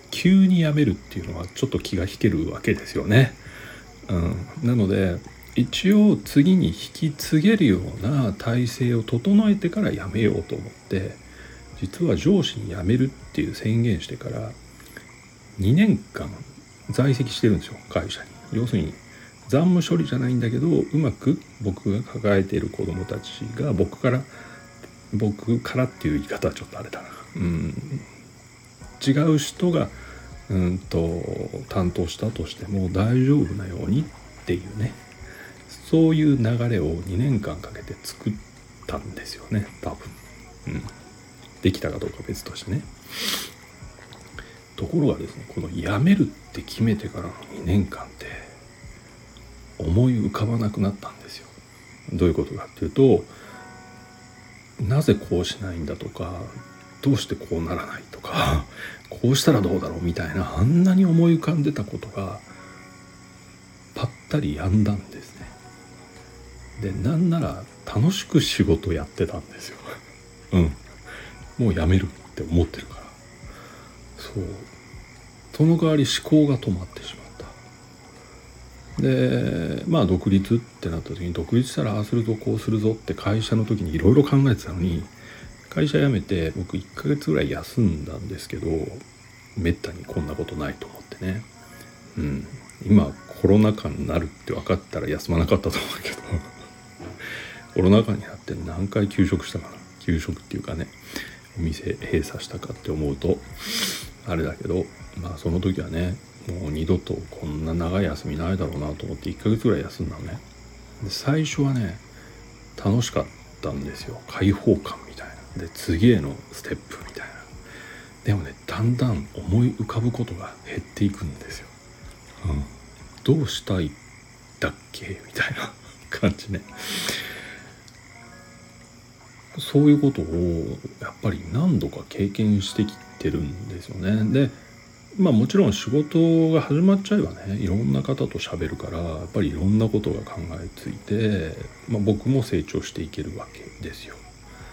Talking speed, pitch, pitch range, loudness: 295 characters per minute, 105 Hz, 90-125 Hz, -24 LUFS